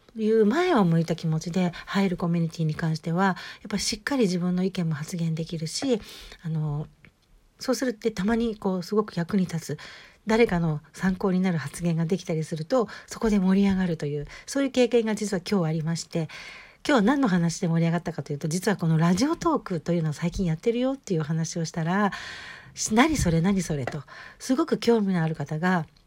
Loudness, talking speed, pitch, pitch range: -26 LUFS, 405 characters per minute, 180 Hz, 165-215 Hz